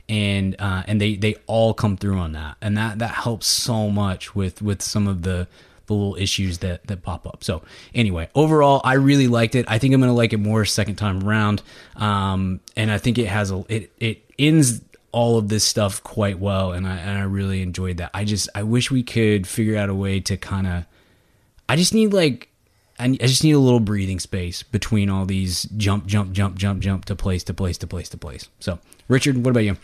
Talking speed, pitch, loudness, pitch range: 230 wpm, 105 Hz, -21 LUFS, 95-115 Hz